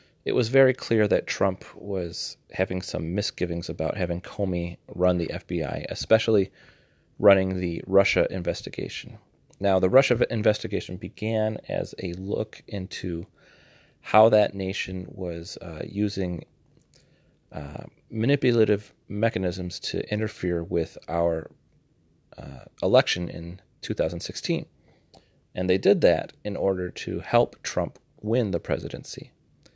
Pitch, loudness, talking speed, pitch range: 95 Hz, -26 LUFS, 120 wpm, 85-105 Hz